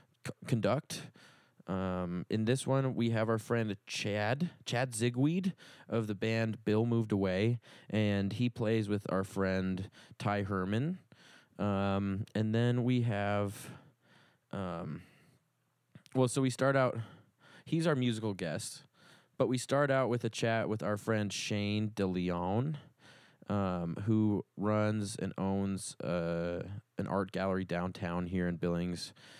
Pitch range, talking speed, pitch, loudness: 95-125 Hz, 135 wpm, 110 Hz, -34 LUFS